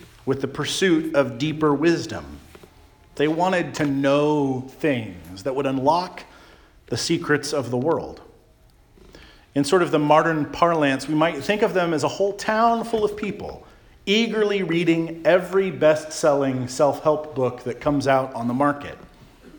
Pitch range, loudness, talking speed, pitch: 135-170 Hz, -22 LUFS, 155 wpm, 150 Hz